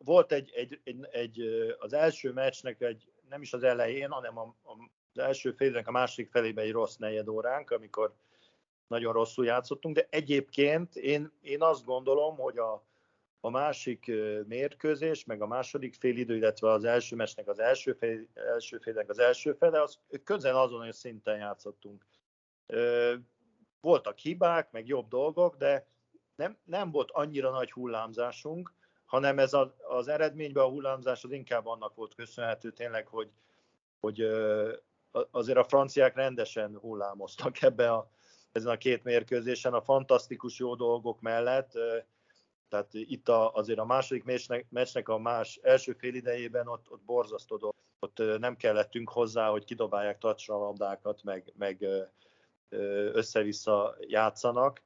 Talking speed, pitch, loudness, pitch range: 145 wpm, 125 Hz, -31 LUFS, 115-150 Hz